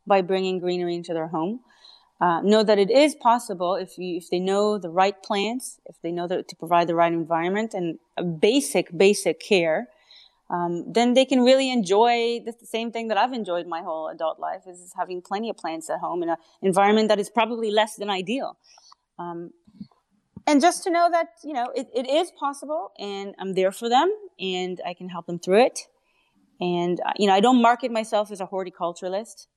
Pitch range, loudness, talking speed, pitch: 180-235 Hz, -23 LUFS, 200 wpm, 200 Hz